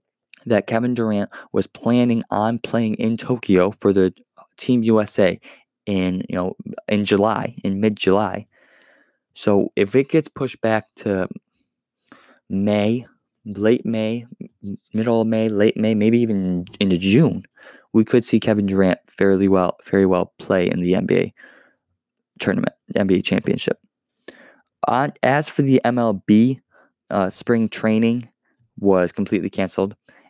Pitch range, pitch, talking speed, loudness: 100-115 Hz, 110 Hz, 135 wpm, -20 LUFS